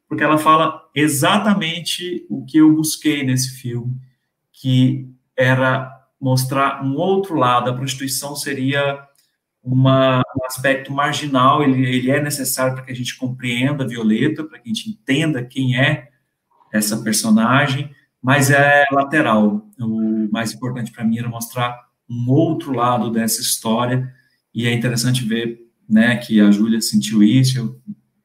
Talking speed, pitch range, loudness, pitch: 145 wpm, 120-145 Hz, -17 LUFS, 130 Hz